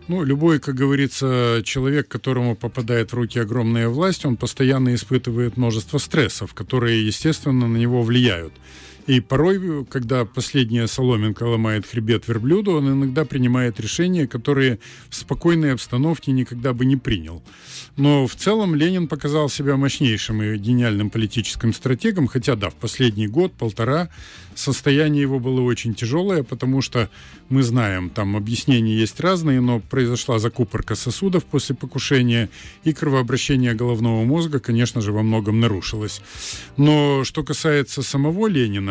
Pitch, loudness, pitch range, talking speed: 125 Hz, -20 LUFS, 115-140 Hz, 140 wpm